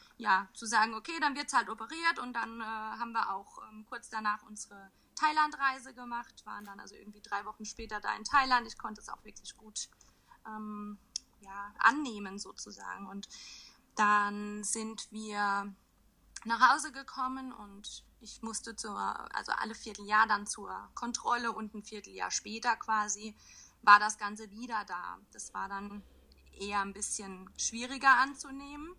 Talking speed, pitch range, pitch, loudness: 155 wpm, 205-240 Hz, 220 Hz, -33 LUFS